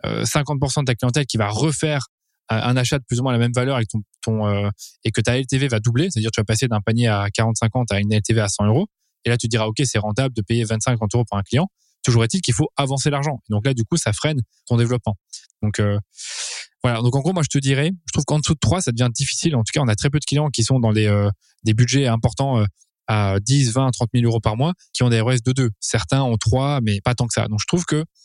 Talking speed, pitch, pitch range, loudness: 285 wpm, 120 Hz, 110-140 Hz, -20 LUFS